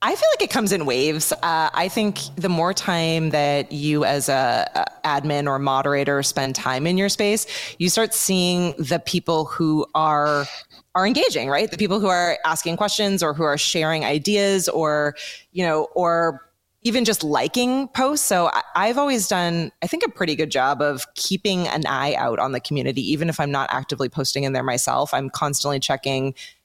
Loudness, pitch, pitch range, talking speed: -21 LUFS, 160 Hz, 145-195 Hz, 195 wpm